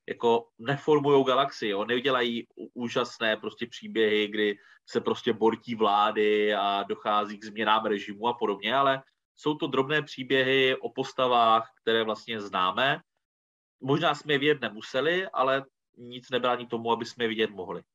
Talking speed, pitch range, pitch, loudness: 150 wpm, 110-135 Hz, 115 Hz, -27 LUFS